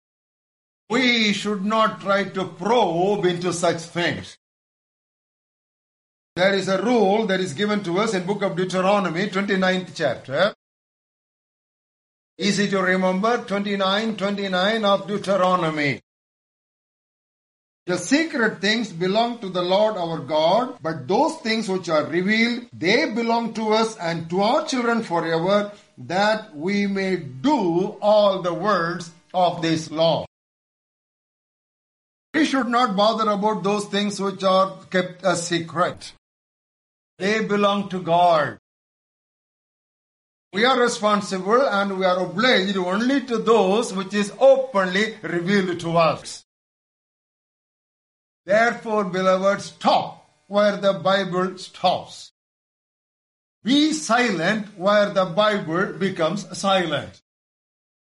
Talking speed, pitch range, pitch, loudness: 115 wpm, 185-220 Hz, 200 Hz, -21 LUFS